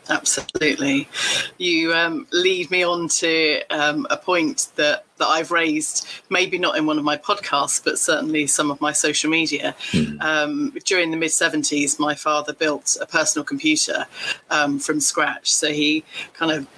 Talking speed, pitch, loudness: 165 wpm, 160 Hz, -20 LUFS